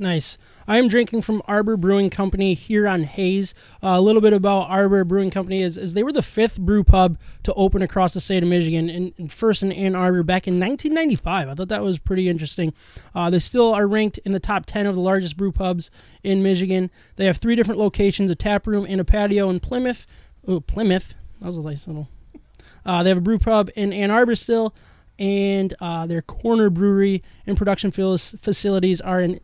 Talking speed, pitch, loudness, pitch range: 215 wpm, 195 Hz, -20 LUFS, 180-205 Hz